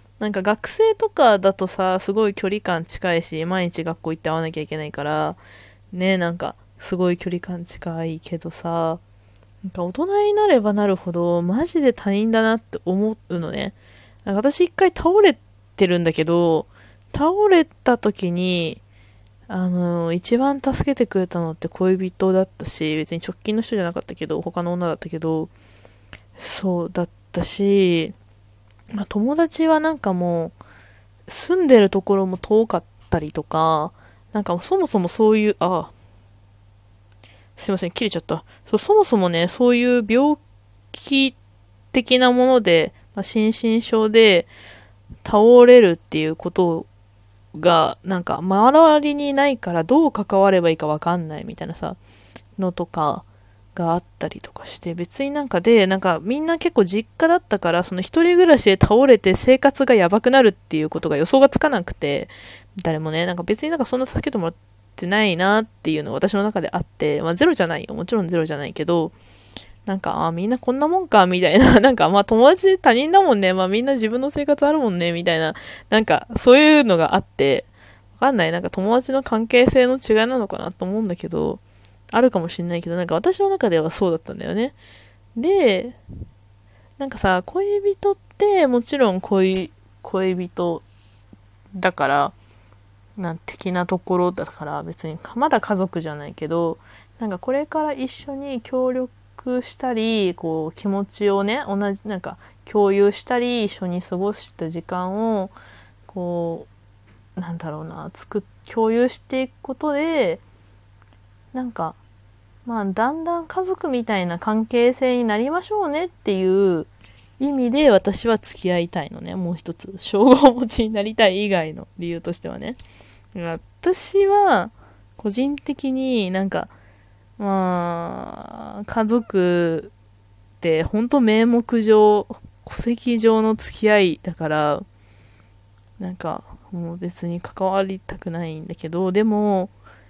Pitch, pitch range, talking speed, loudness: 185 Hz, 155-235 Hz, 305 characters per minute, -19 LUFS